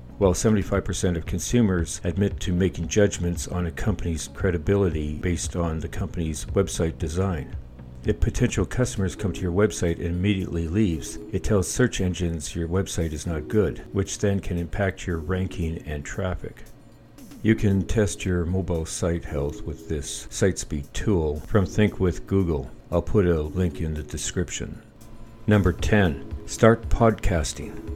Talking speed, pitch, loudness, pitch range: 155 wpm, 90 Hz, -25 LUFS, 80-100 Hz